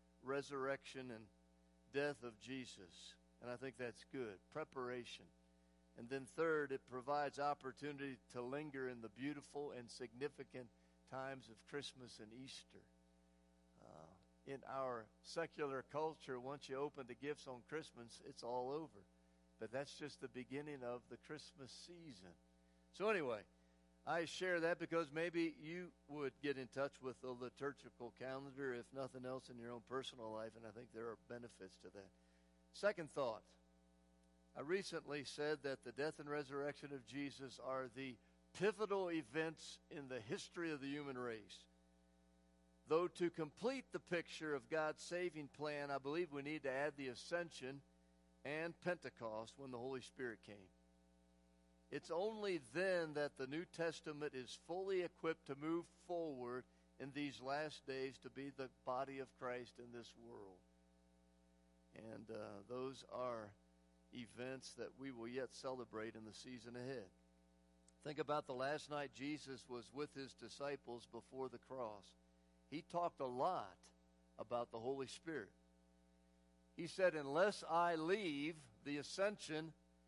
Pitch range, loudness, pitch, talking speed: 105-150 Hz, -47 LUFS, 130 Hz, 150 wpm